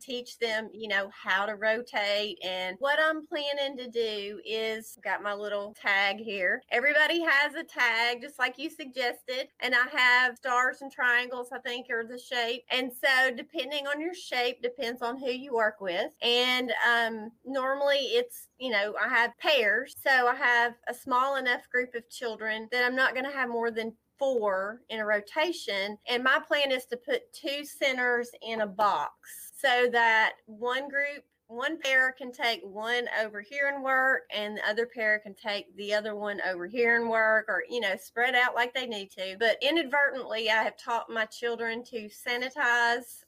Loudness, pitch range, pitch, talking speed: -28 LUFS, 220-265 Hz, 245 Hz, 190 wpm